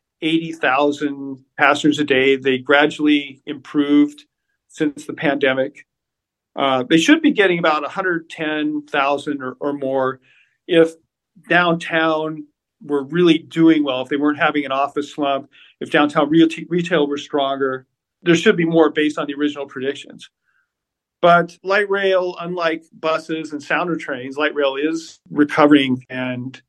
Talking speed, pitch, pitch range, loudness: 140 wpm, 150 Hz, 140-165 Hz, -18 LUFS